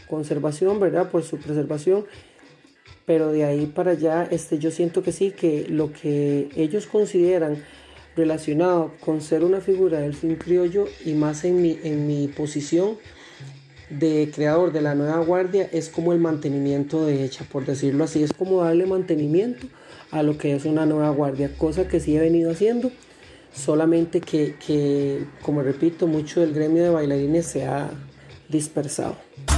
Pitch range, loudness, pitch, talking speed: 150-175 Hz, -22 LUFS, 160 Hz, 160 wpm